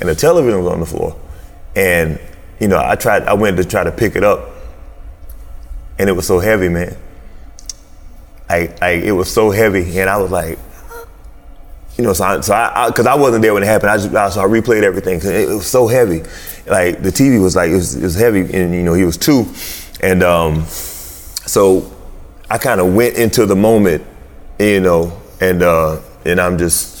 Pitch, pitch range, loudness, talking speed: 90 Hz, 80-95 Hz, -13 LUFS, 215 wpm